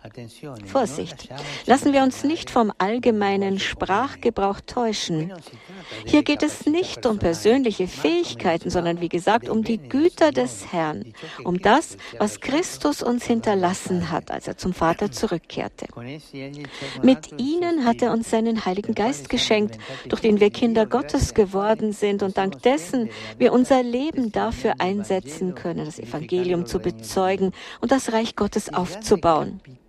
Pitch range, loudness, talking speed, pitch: 180-240 Hz, -22 LUFS, 140 wpm, 205 Hz